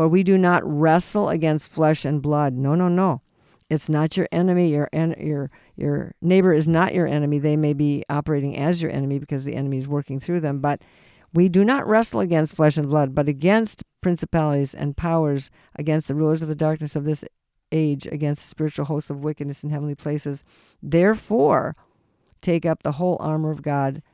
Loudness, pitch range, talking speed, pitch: -22 LUFS, 145-170 Hz, 195 wpm, 155 Hz